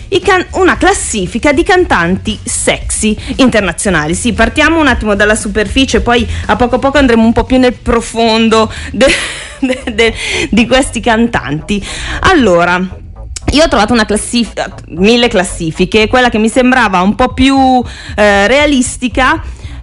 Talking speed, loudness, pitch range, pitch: 140 wpm, -10 LUFS, 215-260 Hz, 235 Hz